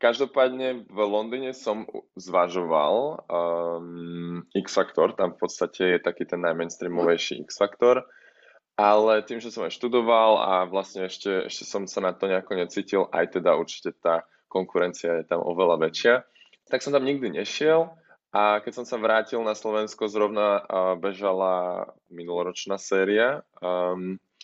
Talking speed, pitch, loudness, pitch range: 145 wpm, 100 Hz, -25 LUFS, 90-115 Hz